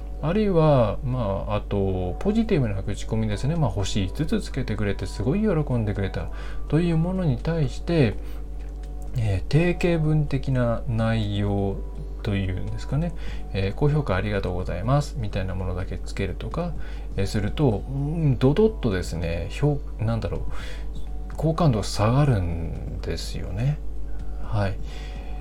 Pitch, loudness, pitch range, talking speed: 115 Hz, -25 LUFS, 95-145 Hz, 300 characters per minute